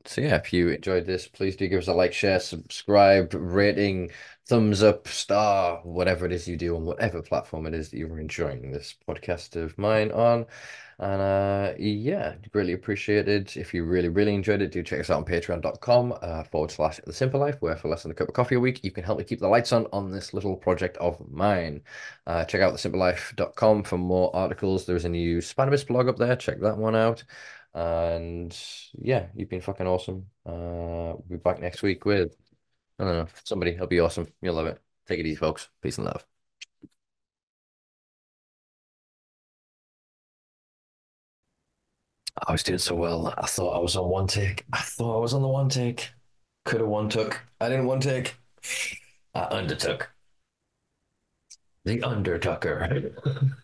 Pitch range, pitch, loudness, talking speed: 85-110 Hz, 95 Hz, -26 LUFS, 185 wpm